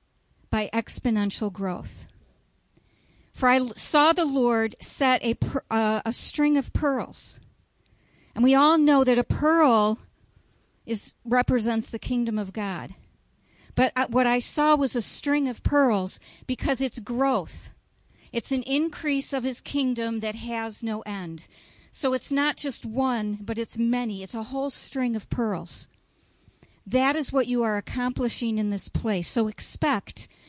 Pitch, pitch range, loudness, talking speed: 245 Hz, 220-270 Hz, -25 LUFS, 150 wpm